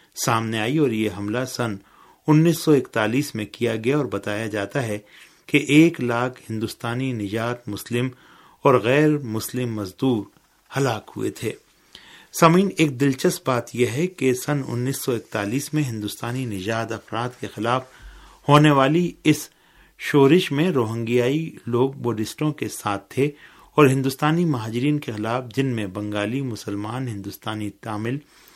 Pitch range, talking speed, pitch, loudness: 110-145 Hz, 145 wpm, 125 Hz, -22 LUFS